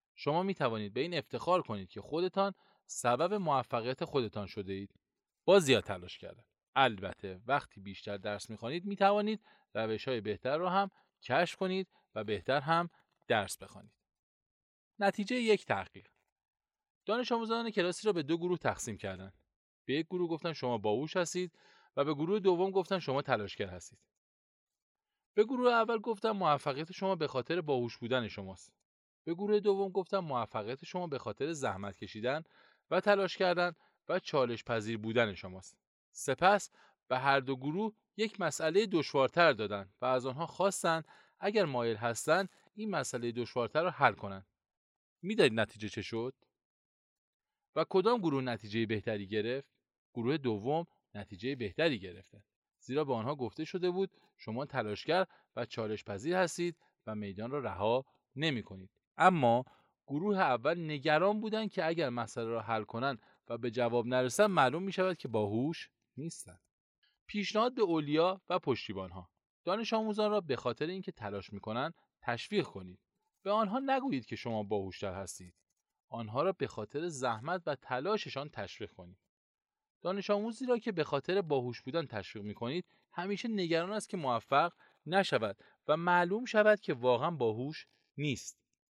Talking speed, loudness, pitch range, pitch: 155 wpm, -34 LUFS, 110-190 Hz, 145 Hz